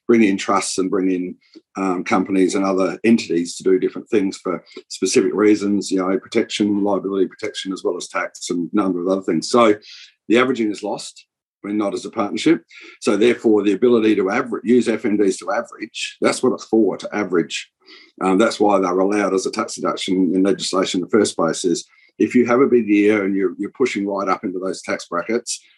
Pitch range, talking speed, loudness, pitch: 95-115 Hz, 215 wpm, -19 LUFS, 100 Hz